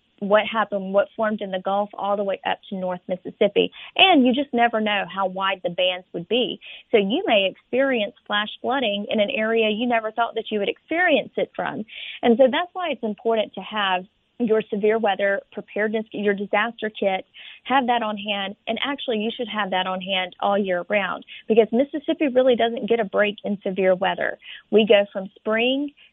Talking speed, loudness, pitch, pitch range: 200 wpm, -22 LUFS, 215 Hz, 200-240 Hz